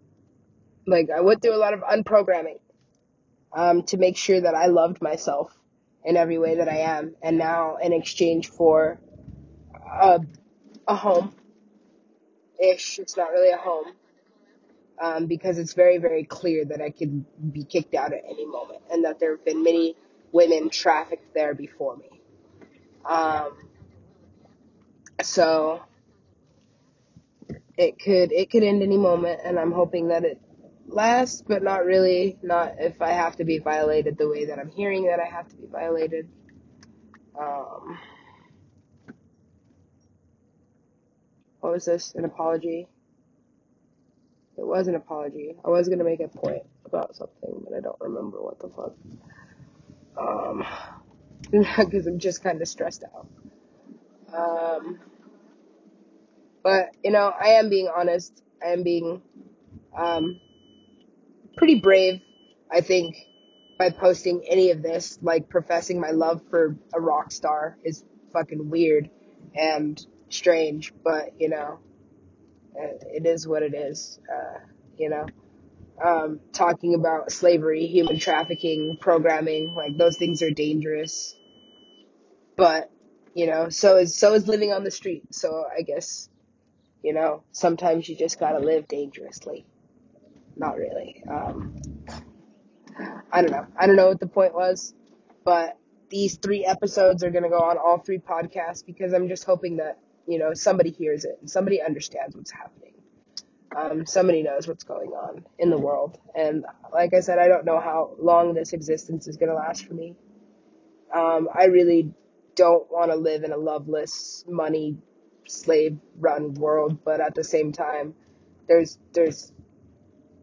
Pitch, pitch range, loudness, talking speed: 170 Hz, 160-185 Hz, -23 LUFS, 150 wpm